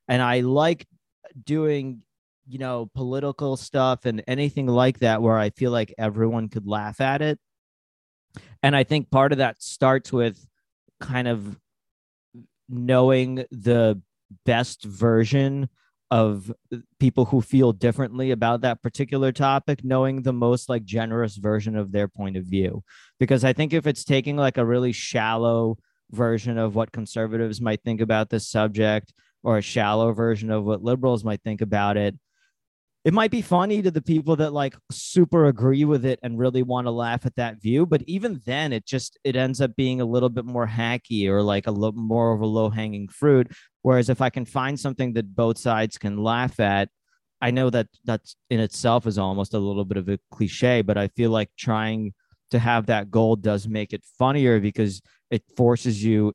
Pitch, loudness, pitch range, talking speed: 120 Hz, -23 LUFS, 110-130 Hz, 185 wpm